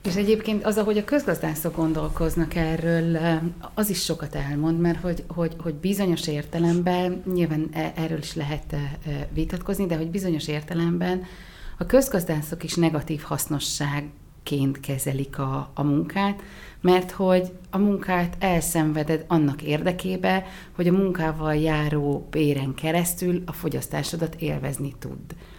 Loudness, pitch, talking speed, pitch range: -25 LUFS, 165 Hz, 125 wpm, 150-180 Hz